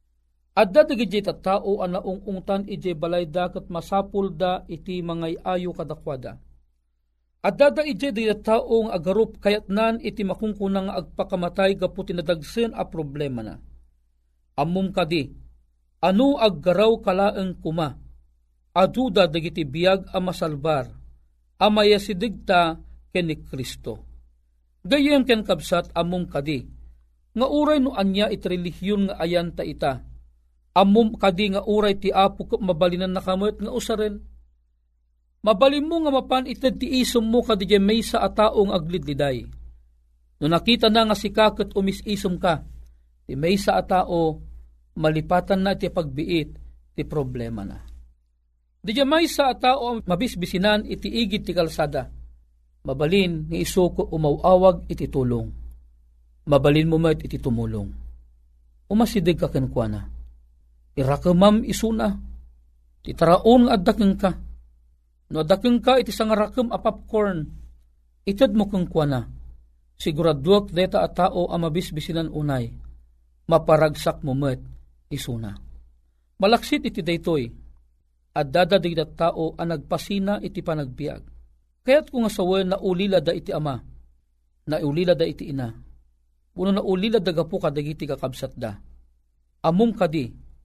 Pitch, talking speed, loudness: 170 Hz, 125 wpm, -22 LUFS